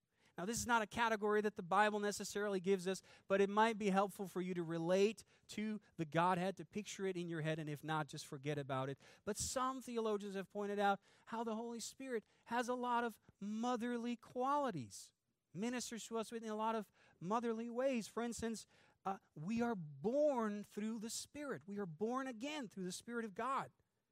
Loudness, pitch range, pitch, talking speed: -41 LUFS, 185-235 Hz, 210 Hz, 200 wpm